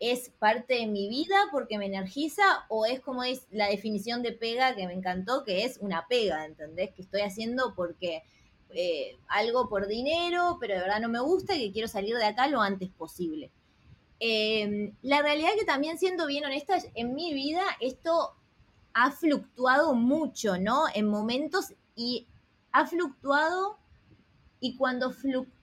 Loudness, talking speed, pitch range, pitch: -29 LUFS, 170 wpm, 205-295 Hz, 245 Hz